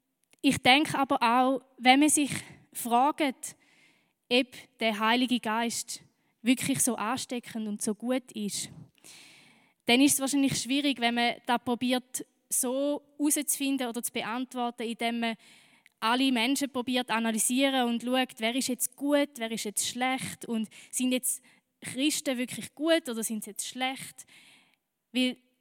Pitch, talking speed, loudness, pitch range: 250 Hz, 145 wpm, -28 LUFS, 230-270 Hz